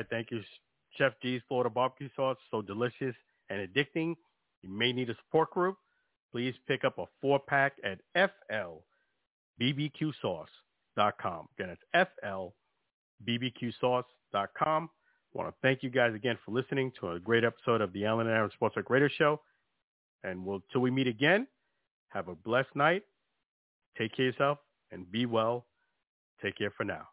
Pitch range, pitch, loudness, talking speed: 115-140 Hz, 125 Hz, -32 LUFS, 155 wpm